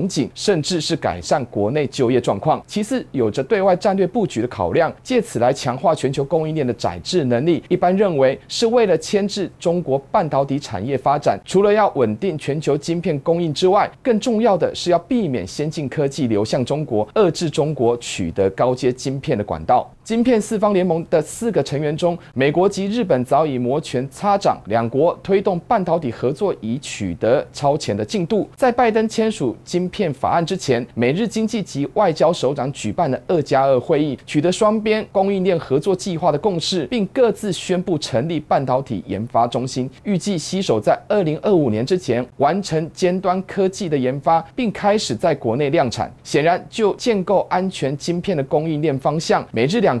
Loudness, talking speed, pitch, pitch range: -19 LUFS, 290 characters per minute, 165 Hz, 135-195 Hz